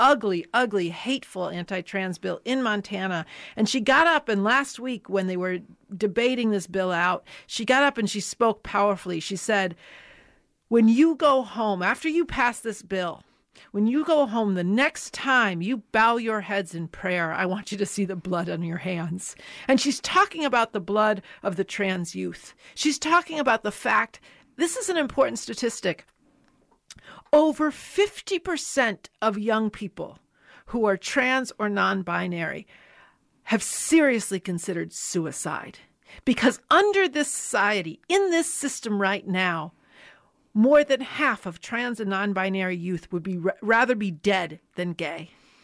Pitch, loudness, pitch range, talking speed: 215 Hz, -24 LUFS, 190-265 Hz, 165 wpm